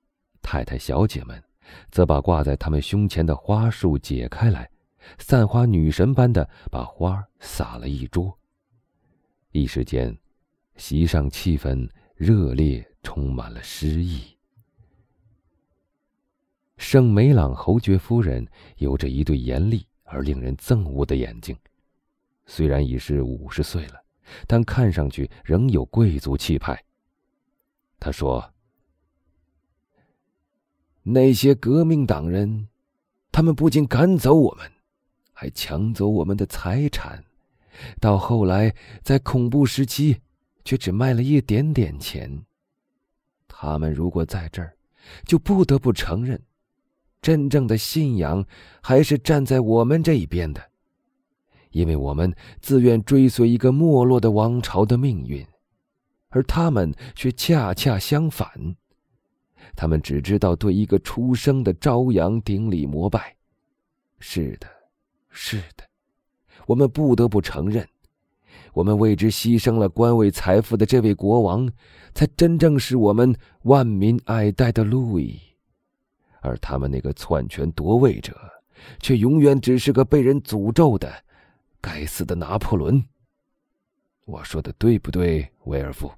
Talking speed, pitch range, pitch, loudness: 190 characters per minute, 80-125 Hz, 105 Hz, -21 LUFS